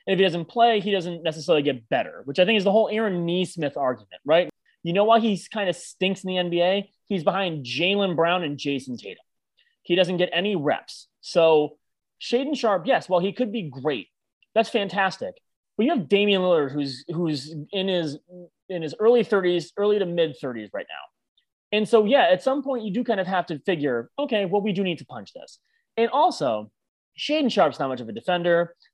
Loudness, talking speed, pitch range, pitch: -23 LUFS, 210 wpm, 160-210 Hz, 185 Hz